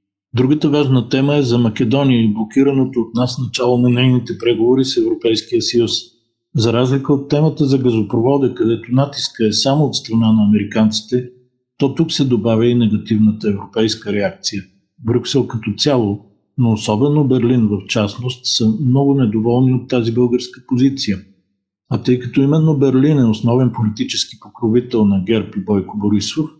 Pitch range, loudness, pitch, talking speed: 110-135 Hz, -16 LUFS, 125 Hz, 155 wpm